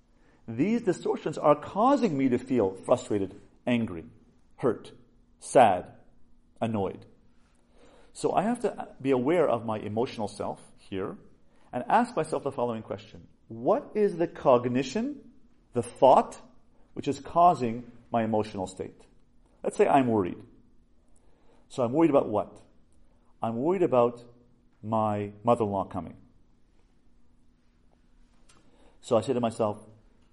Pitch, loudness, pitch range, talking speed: 120 Hz, -27 LUFS, 100-140 Hz, 125 wpm